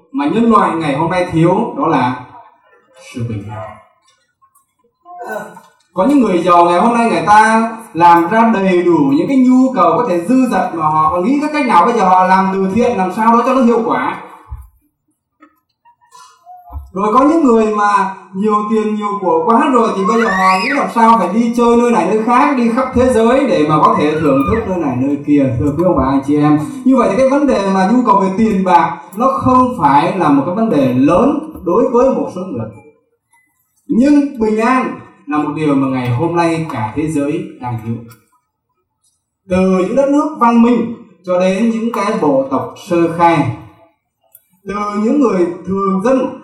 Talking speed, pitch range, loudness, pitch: 205 wpm, 170-255 Hz, -12 LUFS, 215 Hz